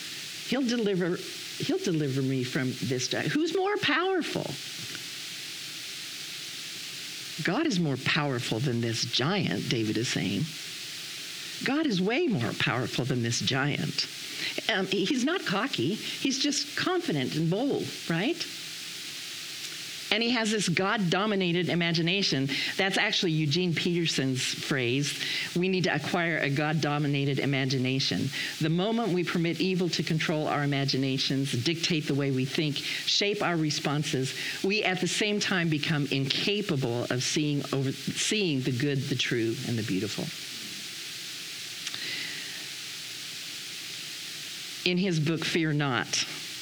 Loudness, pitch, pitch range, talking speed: -28 LUFS, 160 Hz, 140-185 Hz, 125 wpm